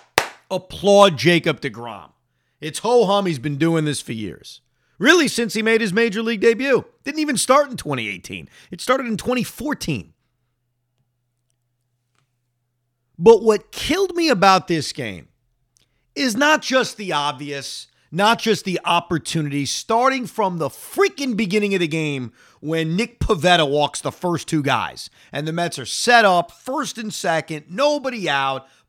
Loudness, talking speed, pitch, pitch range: -19 LUFS, 150 wpm, 170 Hz, 135-230 Hz